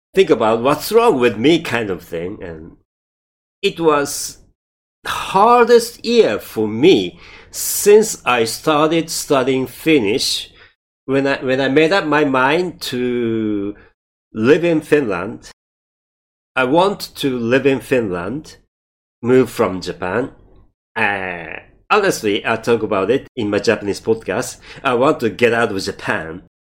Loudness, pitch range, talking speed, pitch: -16 LUFS, 115-160 Hz, 135 wpm, 135 Hz